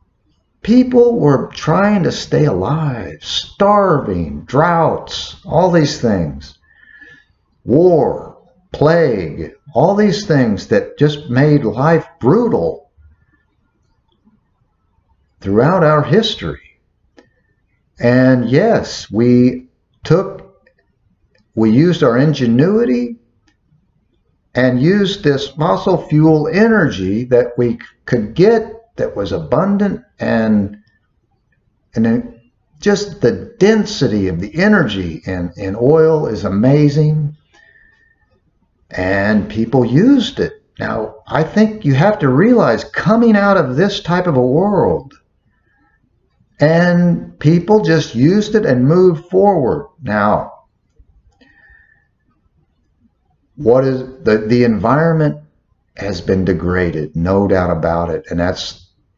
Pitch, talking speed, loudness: 145 Hz, 100 wpm, -14 LUFS